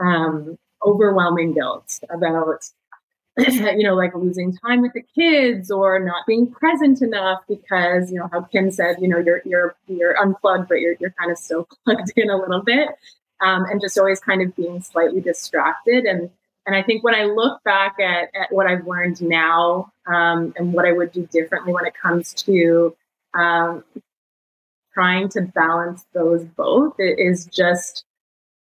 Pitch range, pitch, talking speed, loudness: 175-205 Hz, 180 Hz, 175 wpm, -19 LUFS